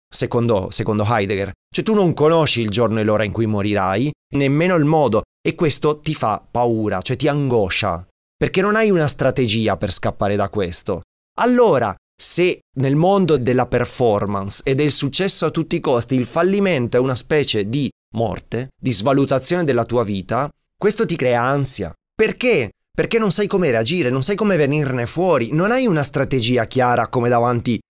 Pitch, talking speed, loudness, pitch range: 130 Hz, 175 wpm, -18 LUFS, 115-160 Hz